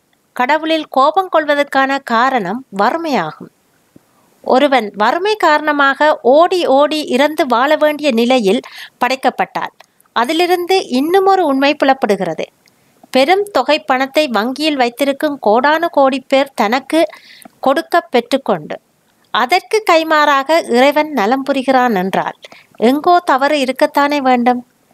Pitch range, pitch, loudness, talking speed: 250-310 Hz, 275 Hz, -13 LUFS, 100 wpm